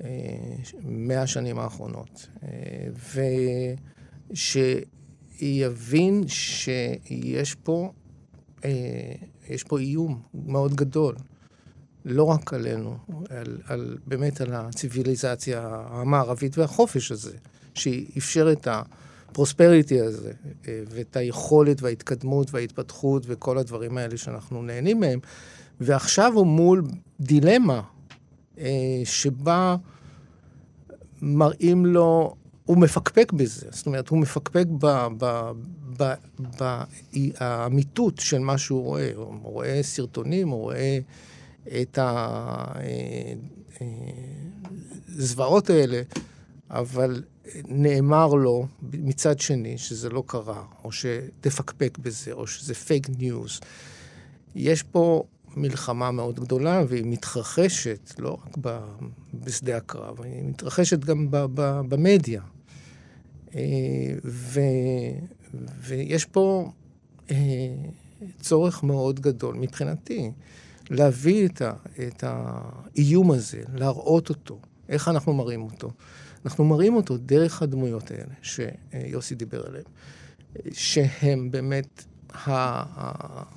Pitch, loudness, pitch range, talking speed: 135 Hz, -24 LUFS, 125-150 Hz, 90 wpm